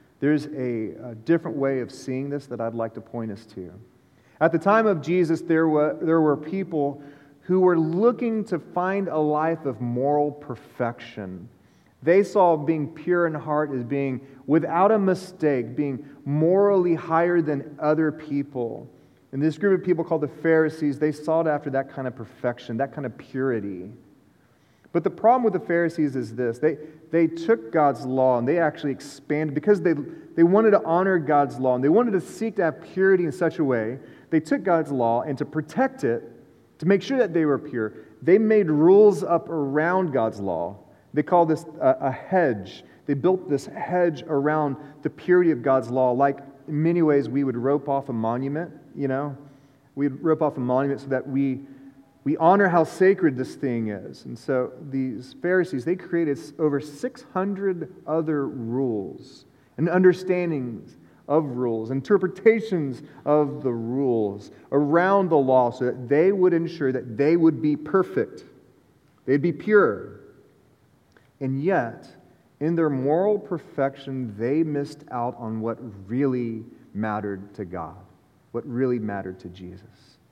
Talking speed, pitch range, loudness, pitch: 170 wpm, 130-170 Hz, -23 LUFS, 150 Hz